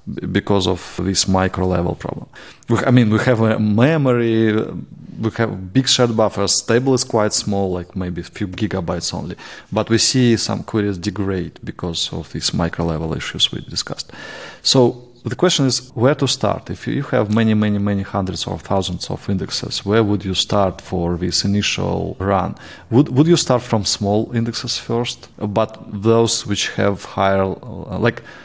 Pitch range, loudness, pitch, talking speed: 95-120 Hz, -18 LUFS, 105 Hz, 170 wpm